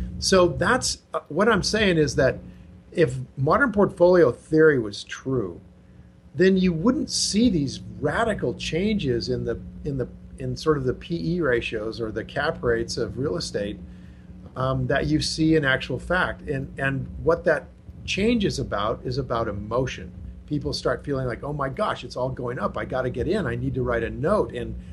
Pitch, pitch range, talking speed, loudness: 135 Hz, 115-160 Hz, 185 wpm, -24 LUFS